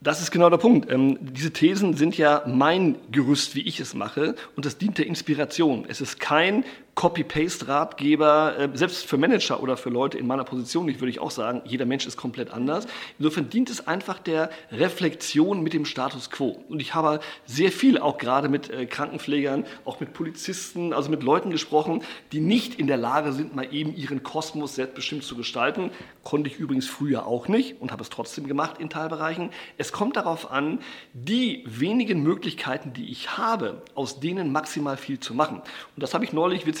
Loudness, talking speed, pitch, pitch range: -25 LUFS, 190 wpm, 155 Hz, 140-170 Hz